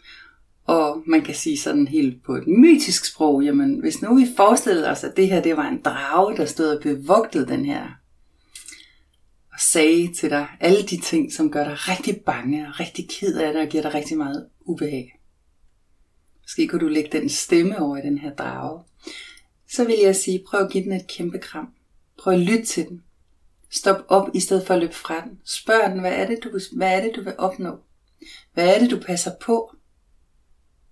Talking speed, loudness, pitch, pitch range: 210 wpm, -20 LUFS, 180 Hz, 150-225 Hz